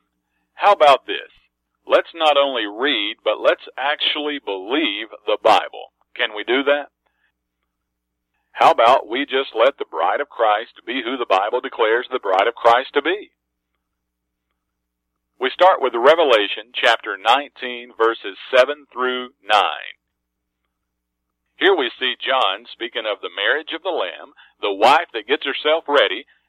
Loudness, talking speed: -18 LUFS, 145 wpm